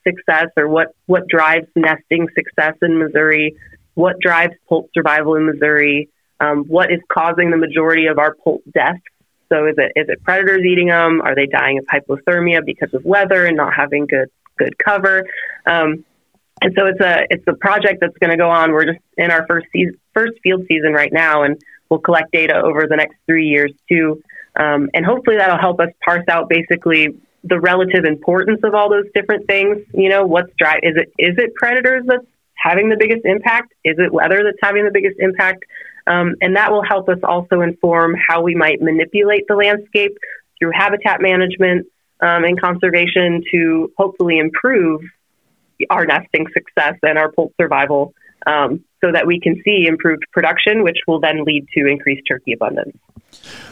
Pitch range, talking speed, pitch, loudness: 160-190 Hz, 185 wpm, 170 Hz, -14 LUFS